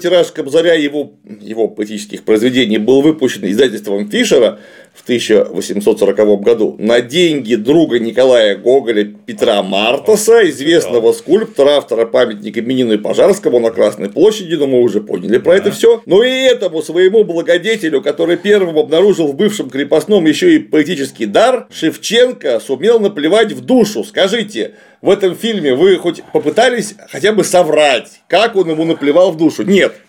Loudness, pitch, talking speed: -12 LUFS, 175 Hz, 150 wpm